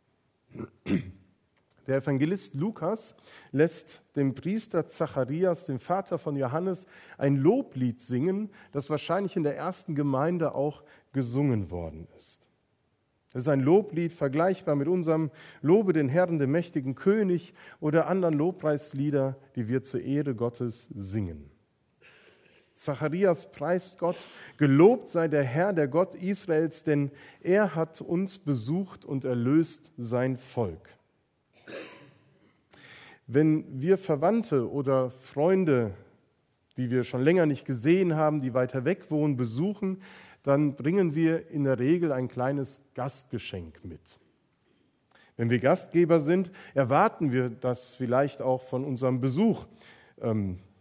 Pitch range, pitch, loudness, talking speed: 130-170 Hz, 145 Hz, -28 LUFS, 125 wpm